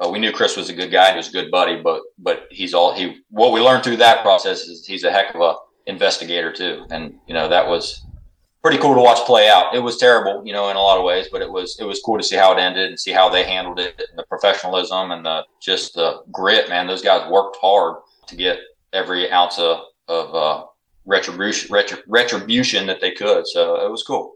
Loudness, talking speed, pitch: -17 LUFS, 250 wpm, 105 Hz